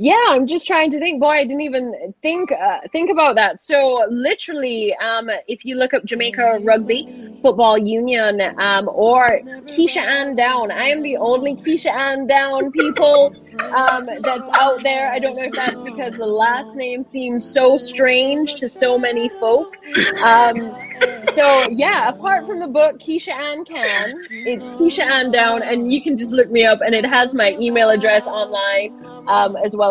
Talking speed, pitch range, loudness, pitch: 180 wpm, 230-290 Hz, -16 LUFS, 255 Hz